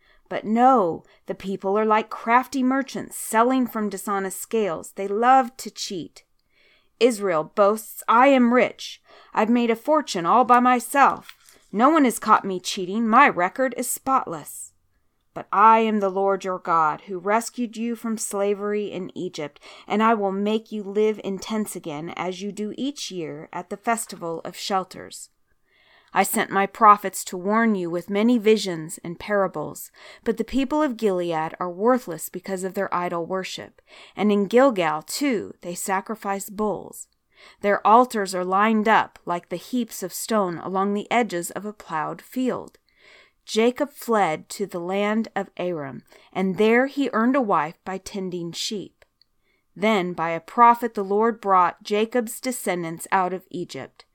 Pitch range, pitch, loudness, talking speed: 185-230 Hz, 205 Hz, -22 LUFS, 165 wpm